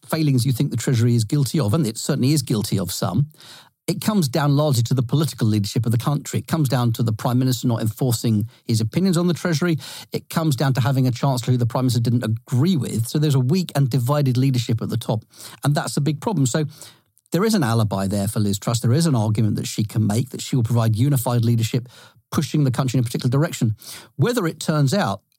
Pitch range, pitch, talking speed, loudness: 115-150 Hz, 130 Hz, 245 wpm, -21 LUFS